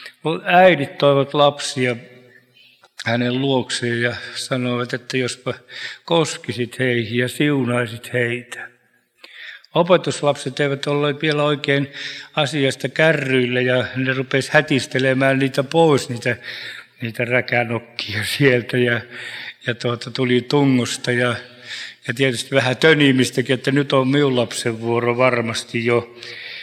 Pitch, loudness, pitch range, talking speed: 130 Hz, -19 LUFS, 120-140 Hz, 110 wpm